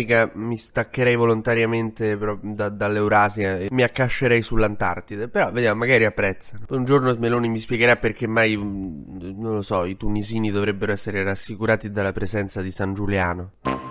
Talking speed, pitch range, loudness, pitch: 140 wpm, 100-115 Hz, -22 LUFS, 105 Hz